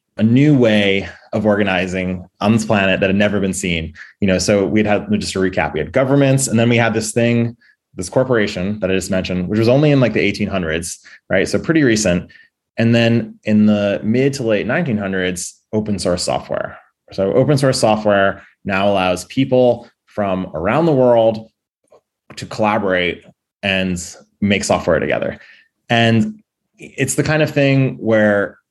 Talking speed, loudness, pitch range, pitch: 175 wpm, -16 LUFS, 95-115 Hz, 105 Hz